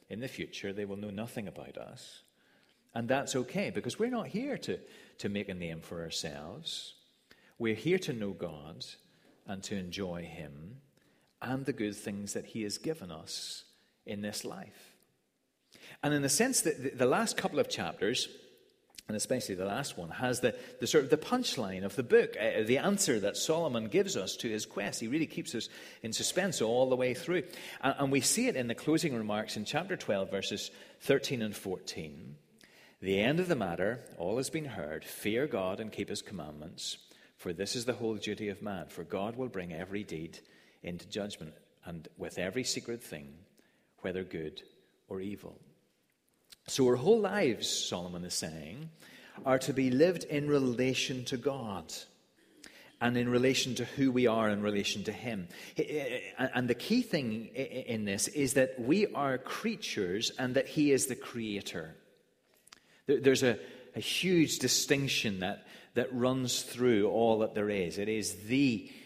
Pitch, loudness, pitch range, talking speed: 125 Hz, -33 LUFS, 105-145 Hz, 175 wpm